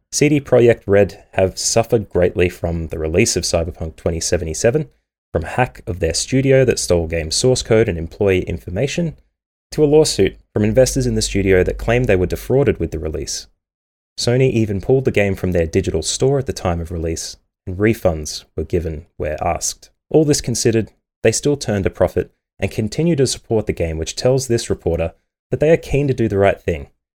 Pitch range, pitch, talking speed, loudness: 85-125 Hz, 100 Hz, 195 wpm, -18 LUFS